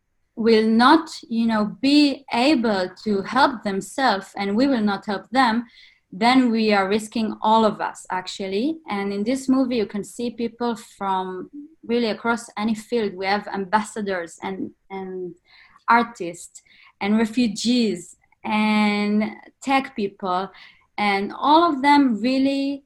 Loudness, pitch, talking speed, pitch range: -21 LUFS, 220 Hz, 135 wpm, 200-255 Hz